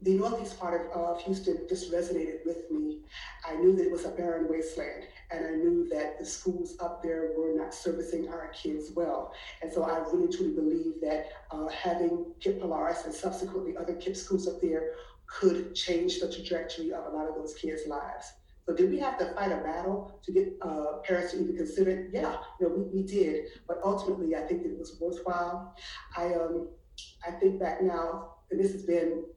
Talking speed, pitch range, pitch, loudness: 205 wpm, 165-195 Hz, 175 Hz, -32 LUFS